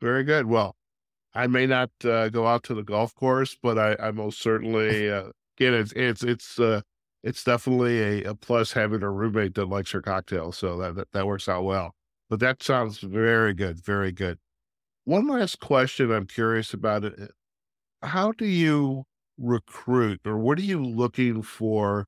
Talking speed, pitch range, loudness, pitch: 180 wpm, 100-125 Hz, -25 LUFS, 110 Hz